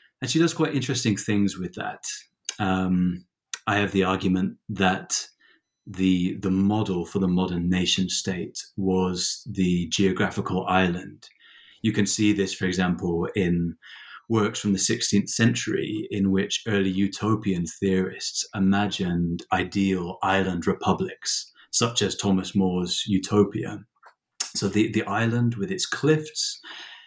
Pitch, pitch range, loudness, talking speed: 95 Hz, 95-105 Hz, -25 LUFS, 130 wpm